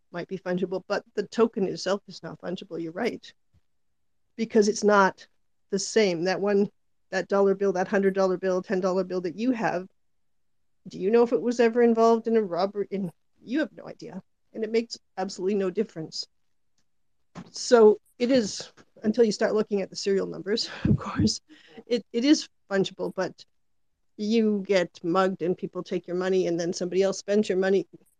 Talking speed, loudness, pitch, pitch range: 185 wpm, -26 LUFS, 195 Hz, 180-215 Hz